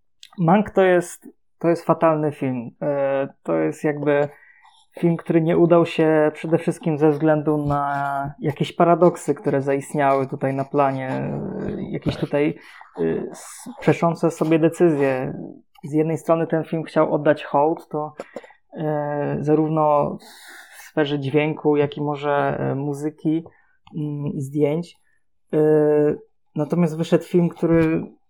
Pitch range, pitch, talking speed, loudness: 145-165 Hz, 155 Hz, 115 wpm, -21 LUFS